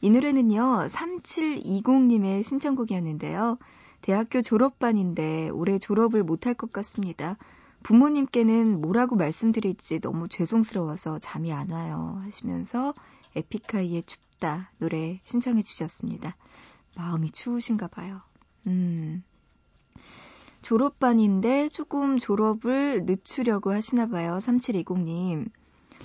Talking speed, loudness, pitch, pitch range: 260 characters per minute, -26 LUFS, 210 Hz, 180-245 Hz